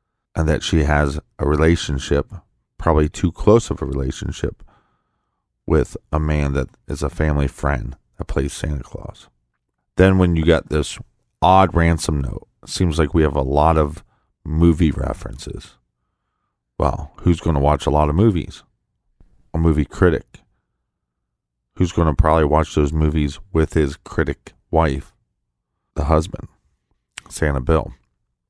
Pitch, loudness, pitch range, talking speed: 75 Hz, -19 LUFS, 70-85 Hz, 140 wpm